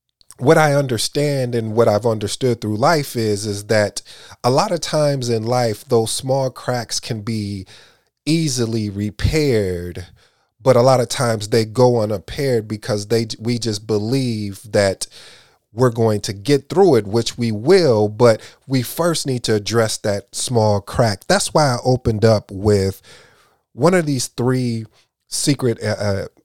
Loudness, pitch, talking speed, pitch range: -18 LUFS, 115 Hz, 155 wpm, 105-130 Hz